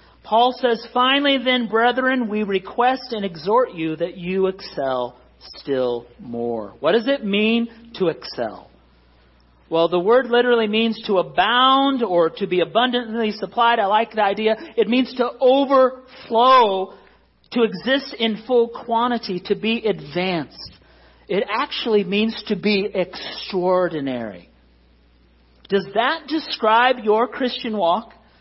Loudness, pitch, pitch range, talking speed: -20 LUFS, 215 Hz, 170-240 Hz, 130 wpm